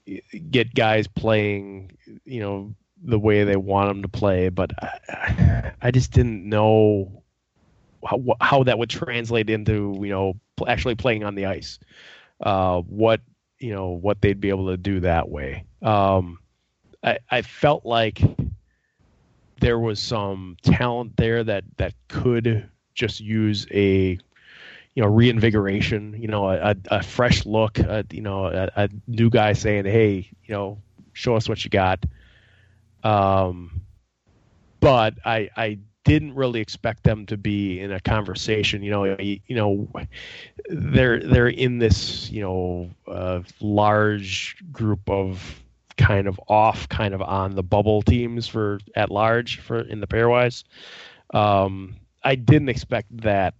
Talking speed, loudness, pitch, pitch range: 150 wpm, -22 LUFS, 105 Hz, 95-115 Hz